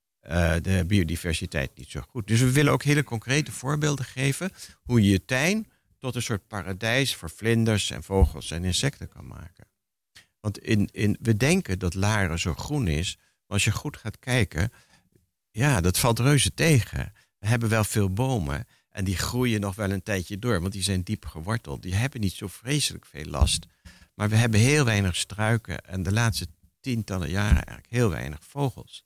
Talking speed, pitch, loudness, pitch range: 190 wpm, 100 Hz, -26 LUFS, 90-120 Hz